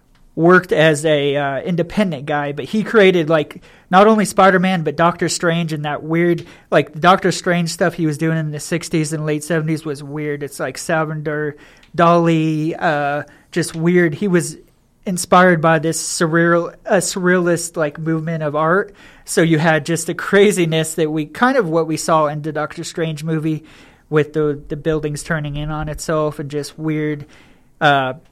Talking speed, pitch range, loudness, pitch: 180 wpm, 150-175 Hz, -17 LUFS, 160 Hz